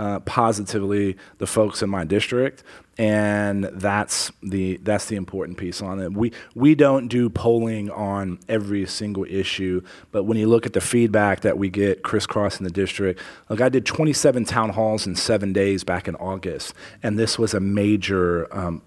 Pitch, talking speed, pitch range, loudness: 100 Hz, 180 wpm, 95-110 Hz, -22 LUFS